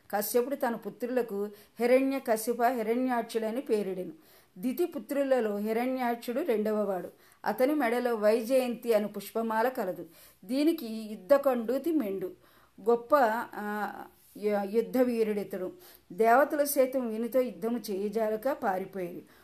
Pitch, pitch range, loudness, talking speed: 230 Hz, 210-255 Hz, -30 LUFS, 95 wpm